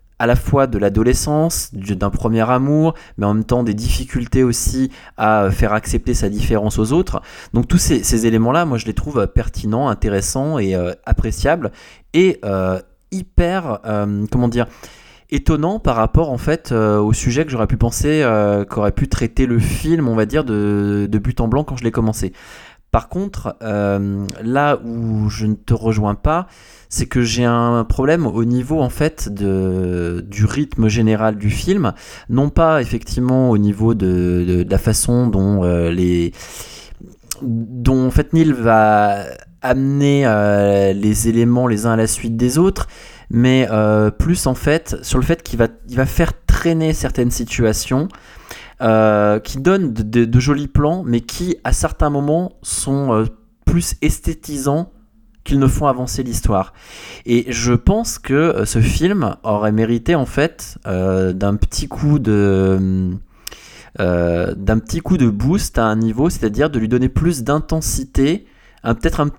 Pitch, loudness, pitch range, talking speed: 115 Hz, -17 LUFS, 105-135 Hz, 170 wpm